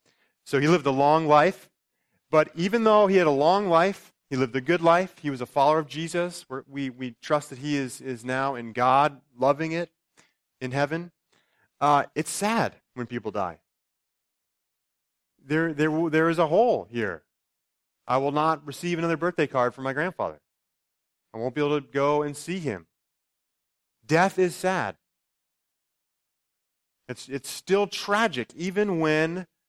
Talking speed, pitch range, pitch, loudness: 160 wpm, 135-175 Hz, 155 Hz, -25 LUFS